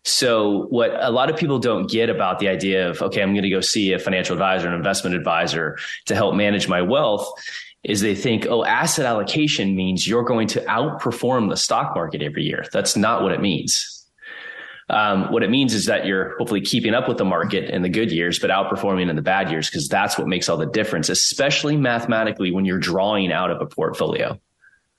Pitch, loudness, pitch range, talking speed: 100 Hz, -20 LUFS, 95-120 Hz, 215 wpm